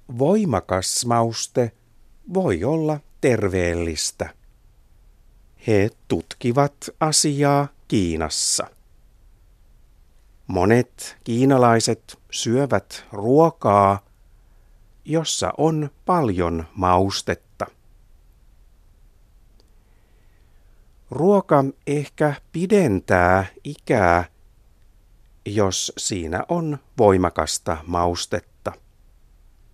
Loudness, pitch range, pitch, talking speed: -21 LUFS, 95-140 Hz, 110 Hz, 50 wpm